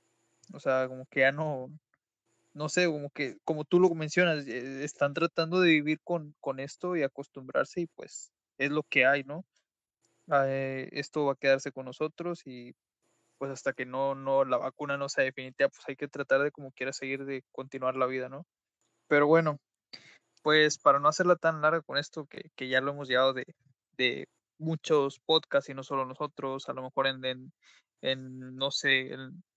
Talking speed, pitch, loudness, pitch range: 190 wpm, 140 Hz, -29 LUFS, 130-155 Hz